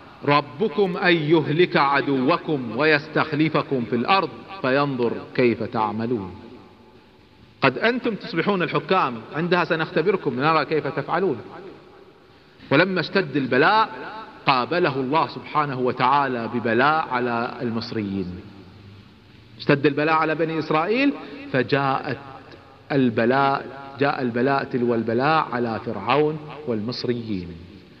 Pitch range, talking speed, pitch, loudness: 120-160 Hz, 90 wpm, 140 Hz, -22 LUFS